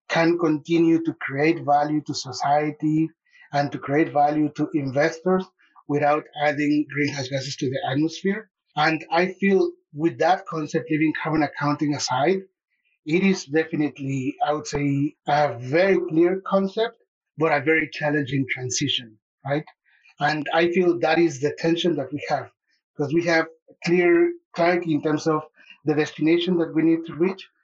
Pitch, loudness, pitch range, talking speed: 155 Hz, -23 LUFS, 145-170 Hz, 155 wpm